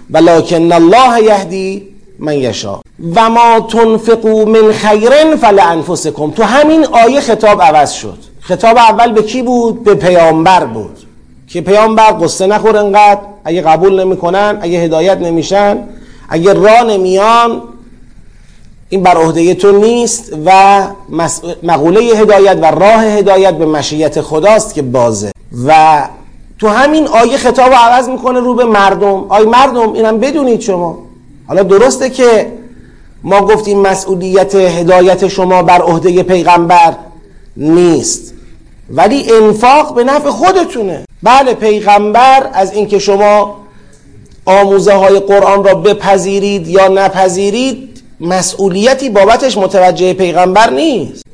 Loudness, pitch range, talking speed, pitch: -8 LUFS, 175-225 Hz, 125 wpm, 200 Hz